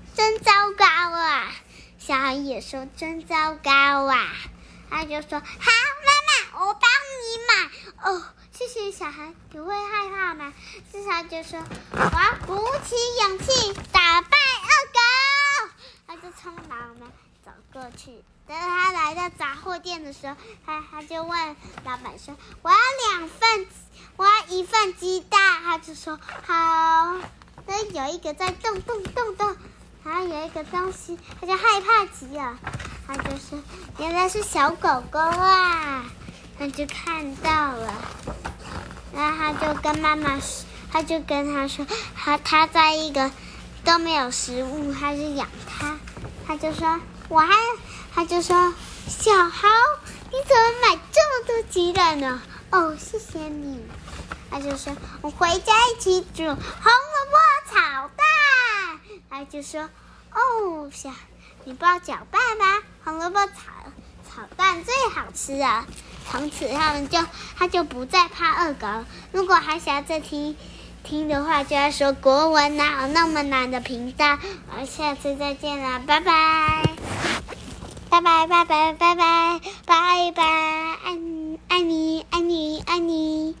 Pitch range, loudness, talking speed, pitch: 295-370 Hz, -21 LUFS, 195 characters per minute, 325 Hz